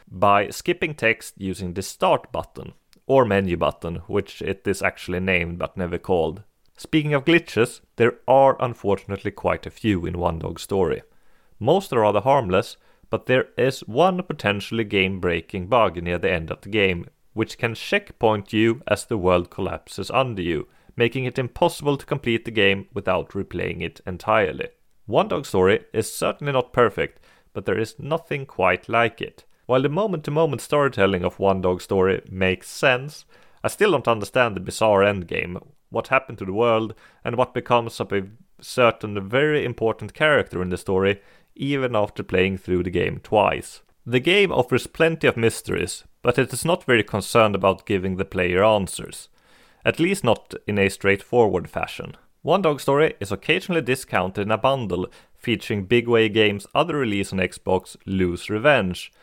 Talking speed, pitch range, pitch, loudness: 170 wpm, 95-130 Hz, 110 Hz, -22 LUFS